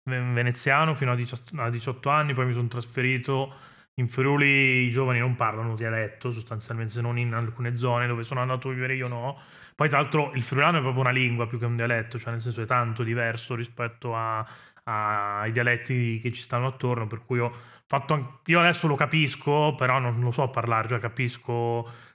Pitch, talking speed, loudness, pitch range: 125 Hz, 200 wpm, -26 LUFS, 120-135 Hz